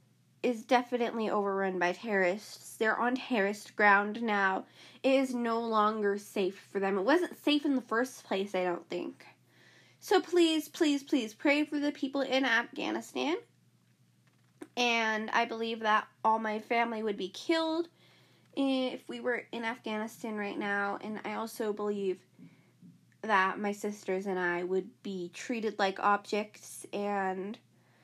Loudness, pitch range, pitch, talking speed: -31 LUFS, 200-250 Hz, 220 Hz, 150 wpm